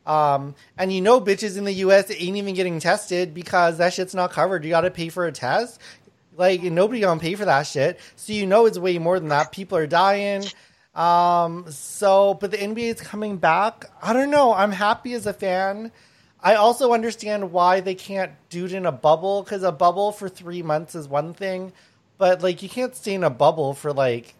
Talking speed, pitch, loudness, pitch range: 215 wpm, 185 Hz, -21 LUFS, 170-200 Hz